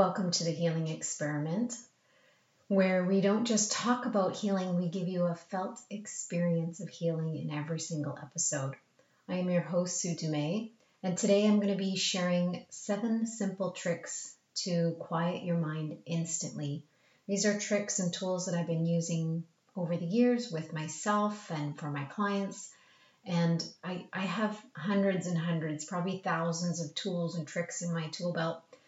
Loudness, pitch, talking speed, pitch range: -33 LUFS, 175 Hz, 165 wpm, 165-195 Hz